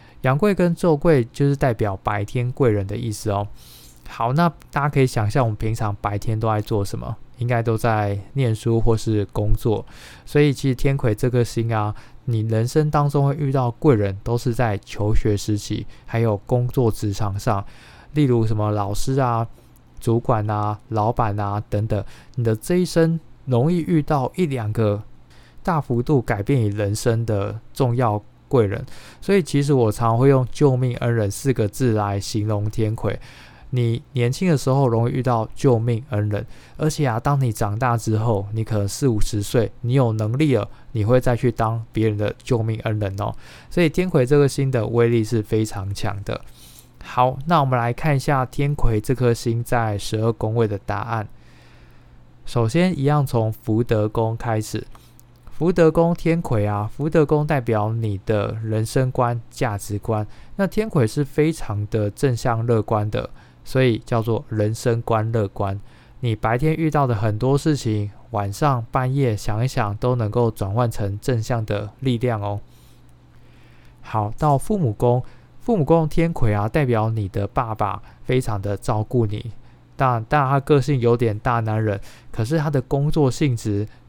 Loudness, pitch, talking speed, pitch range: -21 LUFS, 115 Hz, 245 characters per minute, 110-135 Hz